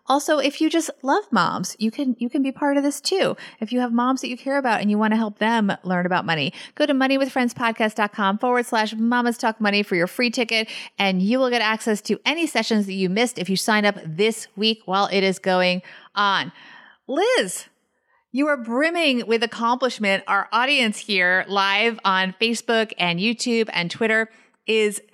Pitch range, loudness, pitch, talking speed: 200-250 Hz, -21 LUFS, 225 Hz, 200 wpm